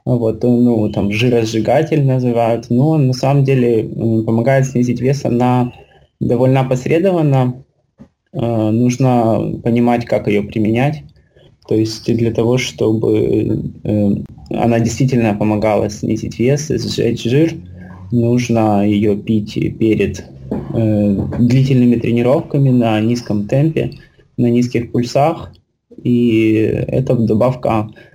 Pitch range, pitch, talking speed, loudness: 110-125 Hz, 115 Hz, 105 wpm, -15 LUFS